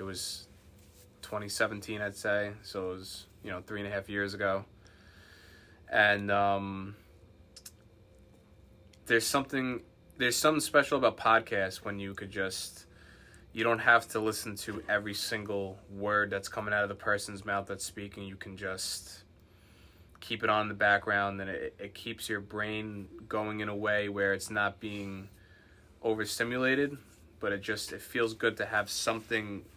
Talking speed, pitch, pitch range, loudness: 160 wpm, 100 Hz, 95-105 Hz, -32 LUFS